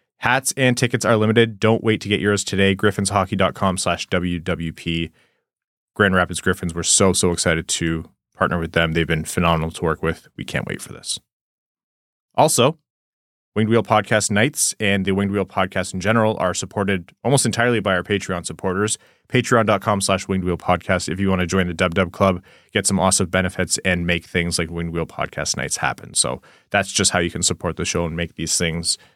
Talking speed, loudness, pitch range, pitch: 200 wpm, -20 LUFS, 85-105 Hz, 95 Hz